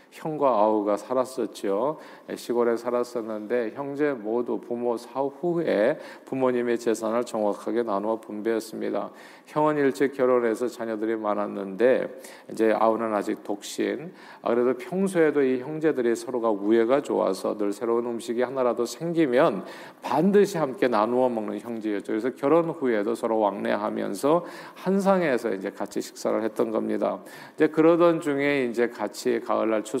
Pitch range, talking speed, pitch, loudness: 110-140 Hz, 335 characters per minute, 120 Hz, -25 LUFS